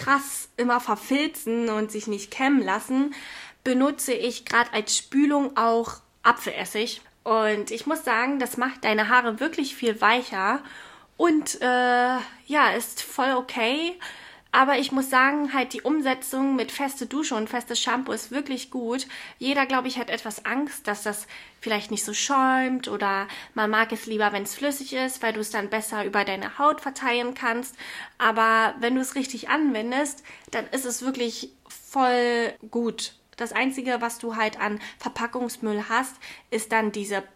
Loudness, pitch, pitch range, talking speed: -25 LUFS, 245 Hz, 220-265 Hz, 165 wpm